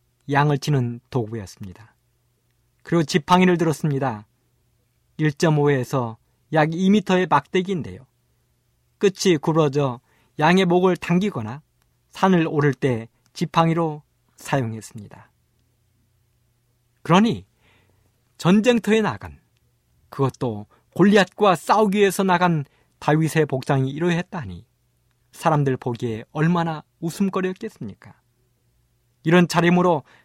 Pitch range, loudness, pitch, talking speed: 120-170 Hz, -20 LUFS, 135 Hz, 240 characters per minute